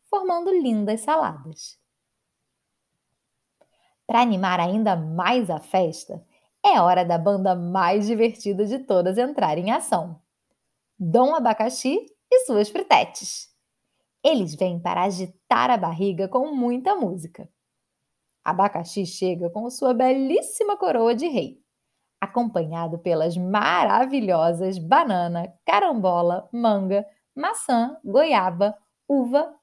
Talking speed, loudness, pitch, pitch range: 105 wpm, -22 LUFS, 205 Hz, 180-255 Hz